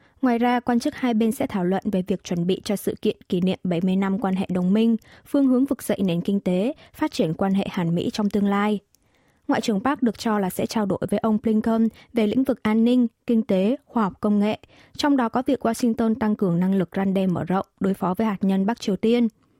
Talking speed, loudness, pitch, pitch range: 255 wpm, -23 LUFS, 215 Hz, 195-235 Hz